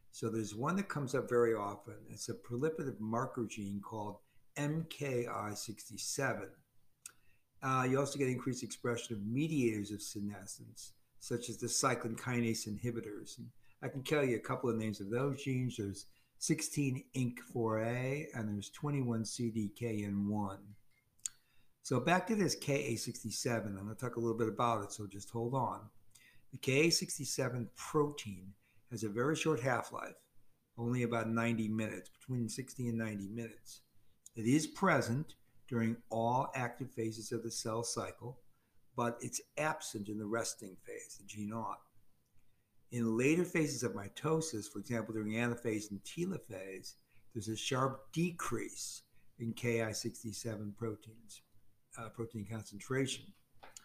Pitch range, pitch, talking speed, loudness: 110-130 Hz, 115 Hz, 140 wpm, -38 LUFS